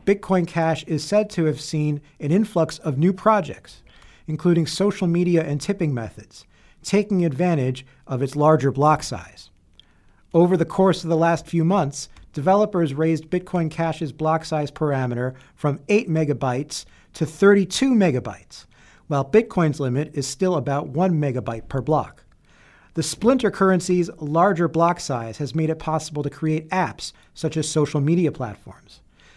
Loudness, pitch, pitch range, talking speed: -21 LUFS, 155 Hz, 140-175 Hz, 150 wpm